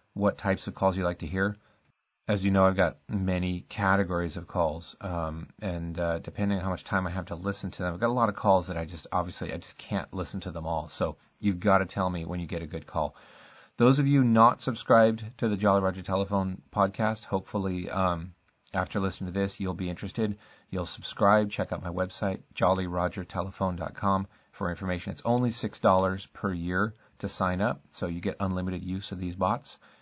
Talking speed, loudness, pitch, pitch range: 210 wpm, -29 LUFS, 95 Hz, 90-100 Hz